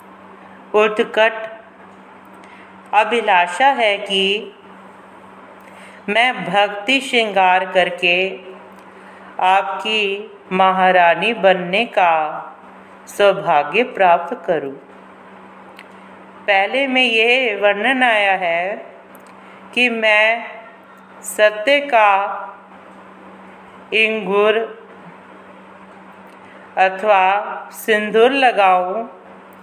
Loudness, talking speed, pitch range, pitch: -15 LUFS, 60 wpm, 190-225 Hz, 205 Hz